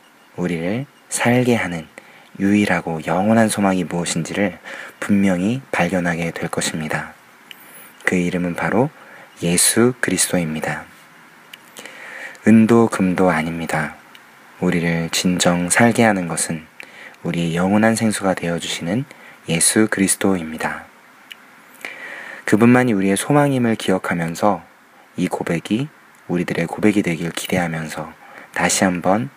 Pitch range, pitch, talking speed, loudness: 85-110 Hz, 95 Hz, 265 characters per minute, -18 LUFS